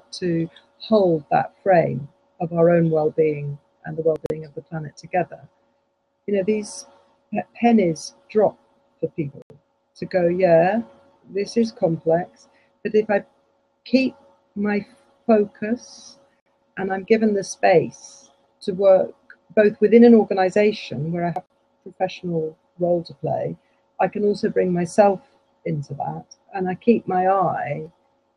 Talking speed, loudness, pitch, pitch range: 140 wpm, -21 LUFS, 185 Hz, 165-210 Hz